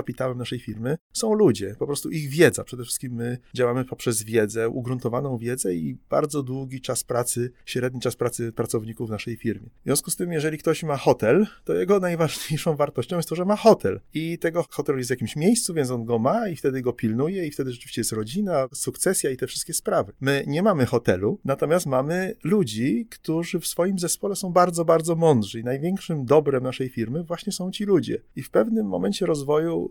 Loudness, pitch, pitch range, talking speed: -24 LUFS, 140 Hz, 125-170 Hz, 200 wpm